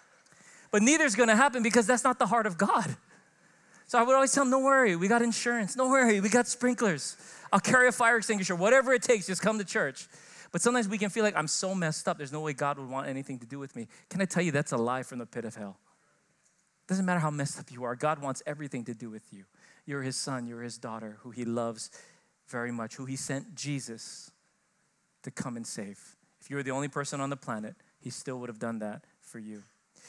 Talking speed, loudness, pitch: 245 wpm, -28 LUFS, 155 Hz